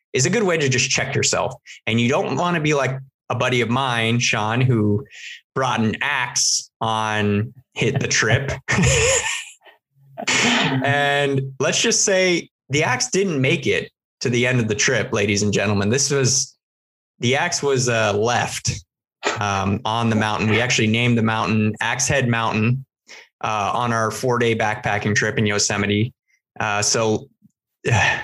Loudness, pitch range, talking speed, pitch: -19 LUFS, 110-135 Hz, 165 wpm, 120 Hz